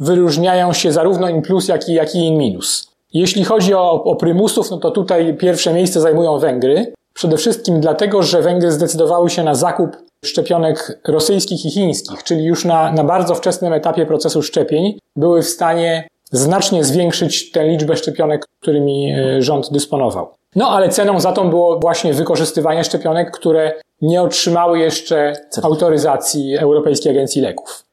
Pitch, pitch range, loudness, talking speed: 165 Hz, 155-180 Hz, -15 LUFS, 155 wpm